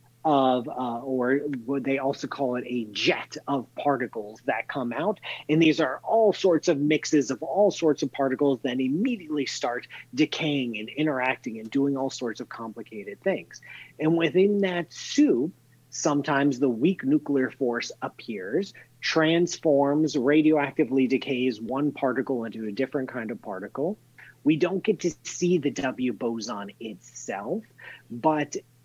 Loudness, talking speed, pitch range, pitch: -26 LUFS, 150 wpm, 130-160 Hz, 140 Hz